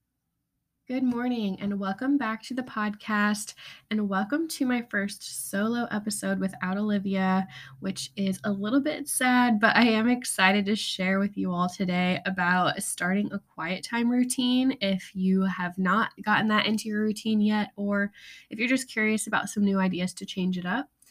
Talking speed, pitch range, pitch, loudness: 175 wpm, 190-230 Hz, 205 Hz, -27 LUFS